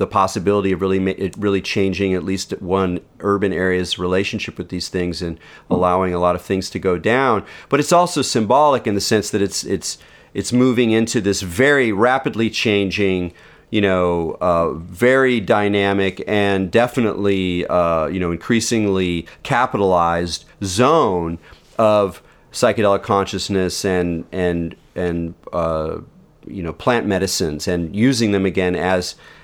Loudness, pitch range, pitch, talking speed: -18 LUFS, 90-105 Hz, 95 Hz, 145 wpm